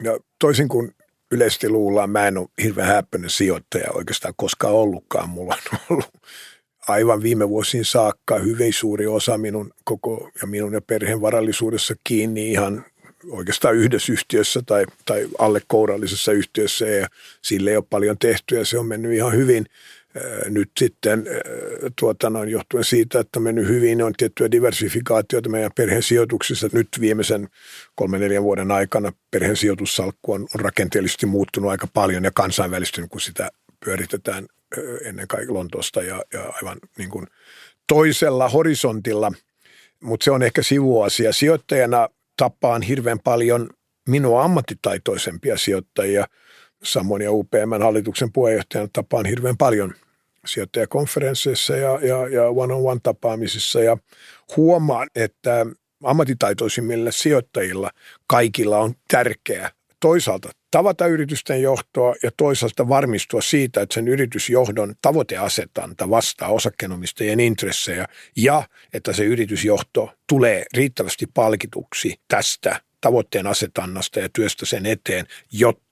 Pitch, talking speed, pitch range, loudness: 115 Hz, 125 wpm, 105-130 Hz, -20 LUFS